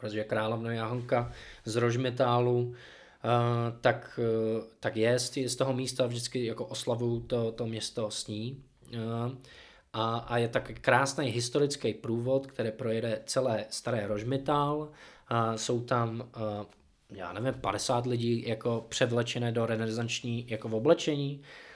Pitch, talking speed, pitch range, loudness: 120 Hz, 120 wpm, 115-125 Hz, -31 LUFS